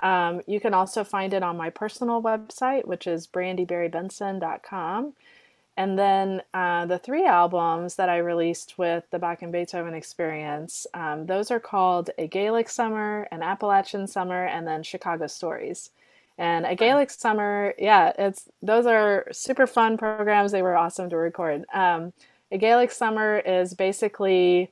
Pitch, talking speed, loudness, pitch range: 190 Hz, 155 wpm, -24 LUFS, 175-215 Hz